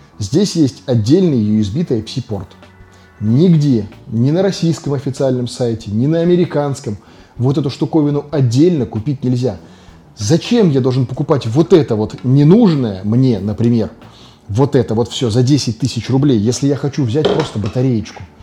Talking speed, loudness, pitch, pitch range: 145 wpm, -15 LUFS, 125 Hz, 110-145 Hz